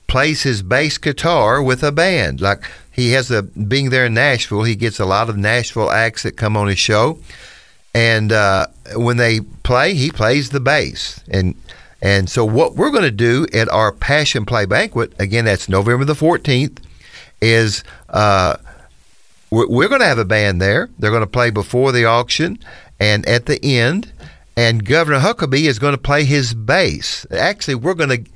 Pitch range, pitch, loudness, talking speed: 105-135 Hz, 120 Hz, -15 LUFS, 185 wpm